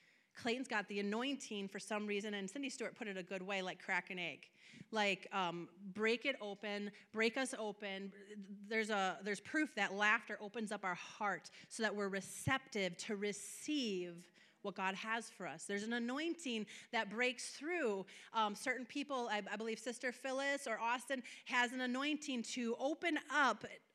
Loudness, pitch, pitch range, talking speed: -41 LUFS, 215 Hz, 200-250 Hz, 175 wpm